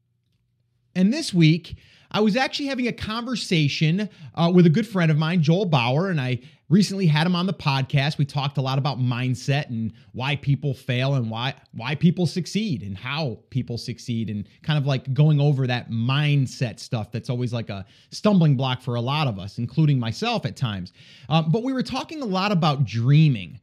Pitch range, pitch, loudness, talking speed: 125-170 Hz, 140 Hz, -23 LUFS, 200 wpm